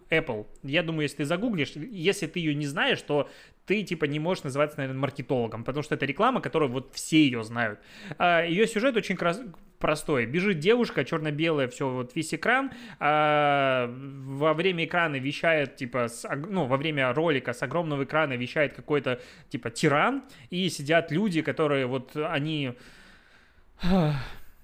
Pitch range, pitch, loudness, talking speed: 135-170 Hz, 150 Hz, -27 LUFS, 155 wpm